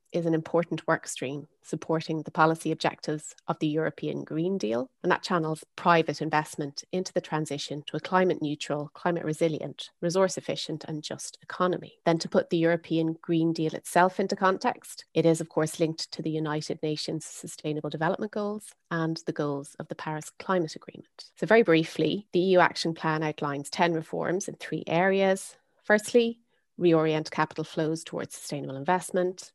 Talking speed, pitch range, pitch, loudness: 170 wpm, 155-180 Hz, 165 Hz, -28 LUFS